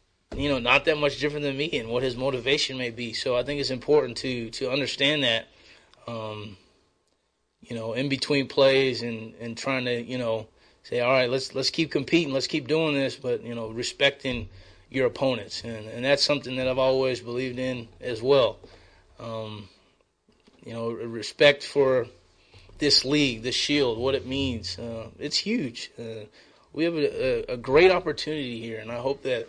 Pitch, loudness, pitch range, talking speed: 130 Hz, -25 LUFS, 115-140 Hz, 185 wpm